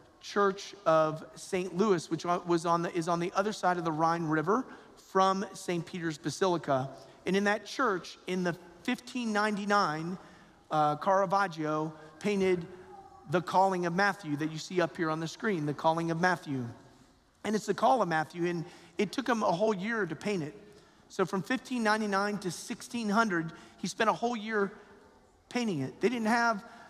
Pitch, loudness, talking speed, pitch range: 190 Hz, -31 LUFS, 175 wpm, 165-205 Hz